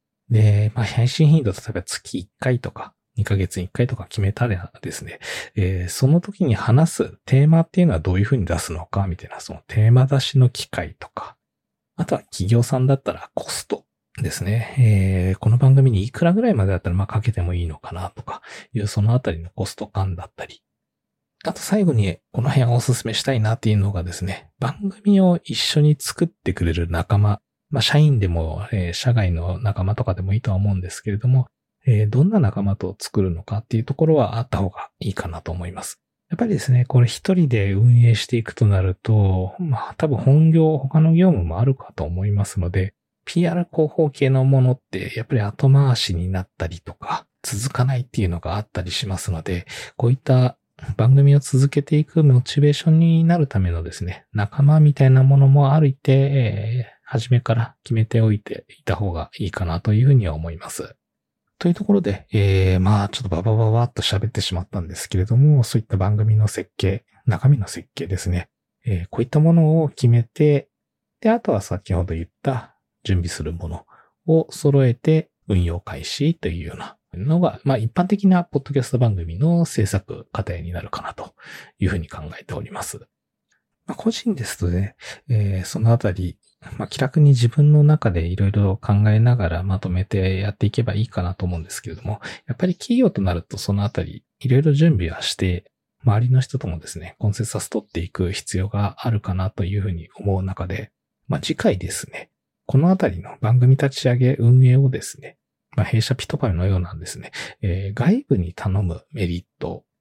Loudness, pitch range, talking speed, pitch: -20 LUFS, 95-135 Hz, 380 characters per minute, 110 Hz